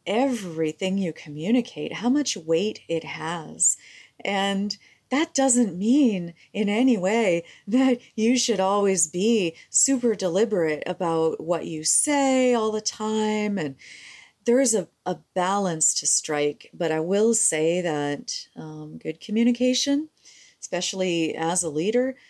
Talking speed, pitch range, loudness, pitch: 130 wpm, 165-245 Hz, -23 LUFS, 200 Hz